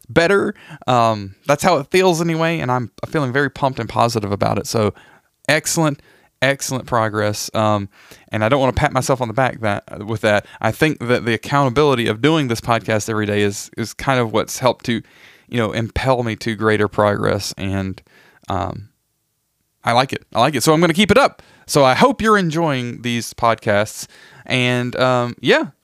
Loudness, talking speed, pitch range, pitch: -18 LUFS, 195 wpm, 110-145 Hz, 120 Hz